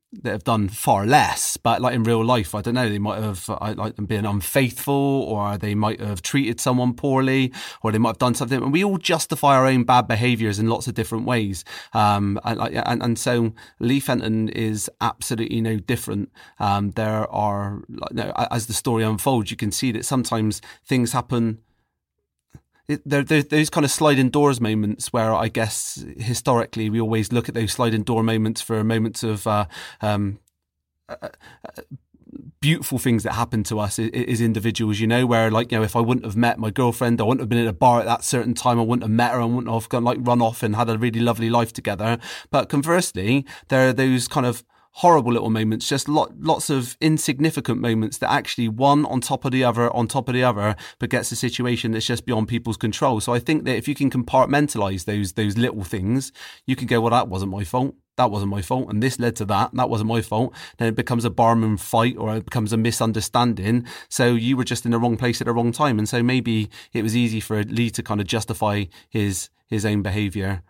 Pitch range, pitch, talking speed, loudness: 110-125 Hz, 115 Hz, 220 wpm, -21 LUFS